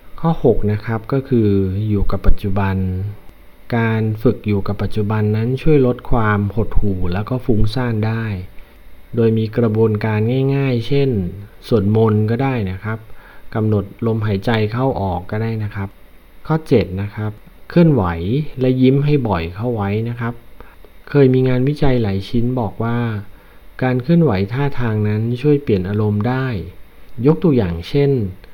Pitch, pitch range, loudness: 110 Hz, 100-125 Hz, -18 LUFS